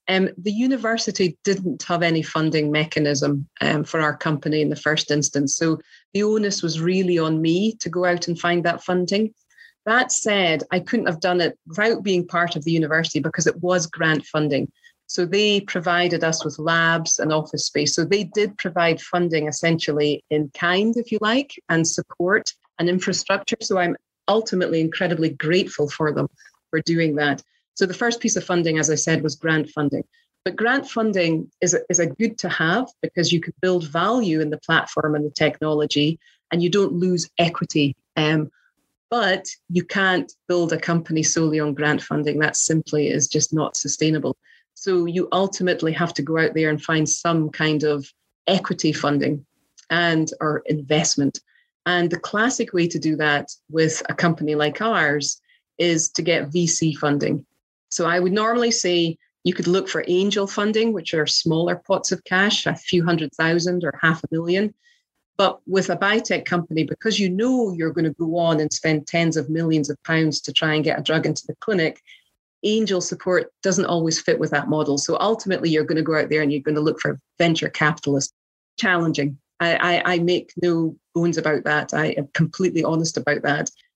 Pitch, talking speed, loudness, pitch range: 165 Hz, 190 wpm, -21 LUFS, 155-185 Hz